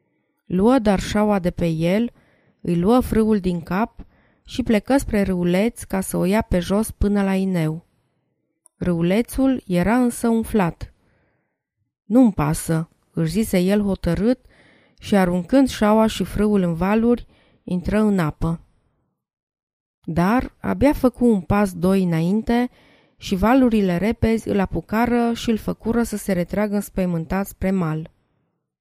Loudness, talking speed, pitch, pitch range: -20 LUFS, 135 wpm, 200 Hz, 175-230 Hz